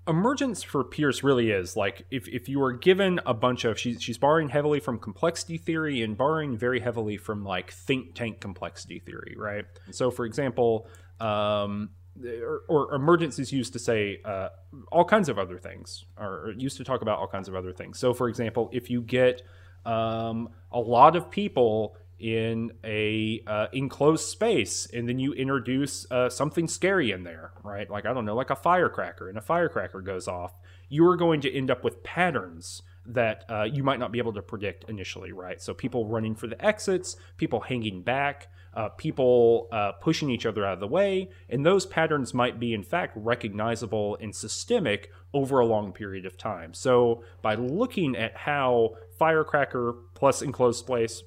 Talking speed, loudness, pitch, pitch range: 185 wpm, -27 LUFS, 115 Hz, 100-135 Hz